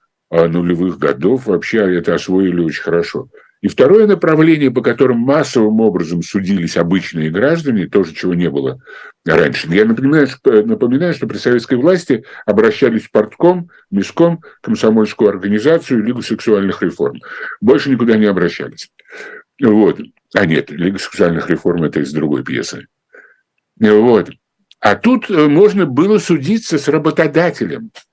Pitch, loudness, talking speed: 135 Hz, -13 LUFS, 130 wpm